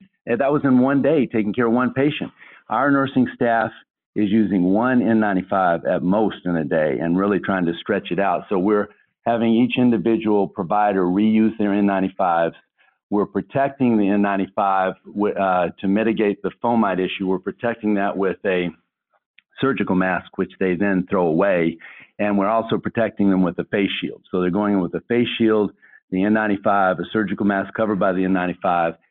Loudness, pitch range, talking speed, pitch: -20 LUFS, 95-115 Hz, 180 wpm, 105 Hz